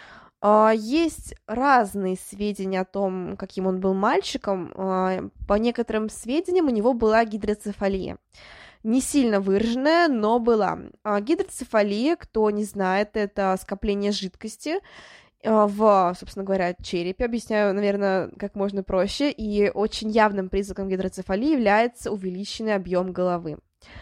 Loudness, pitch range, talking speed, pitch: -24 LUFS, 195-230 Hz, 115 wpm, 205 Hz